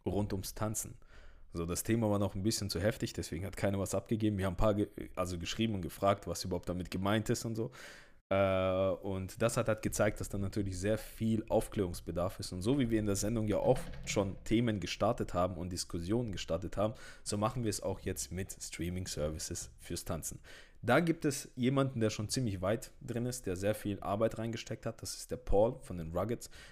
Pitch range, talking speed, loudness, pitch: 90-110 Hz, 215 wpm, -35 LUFS, 100 Hz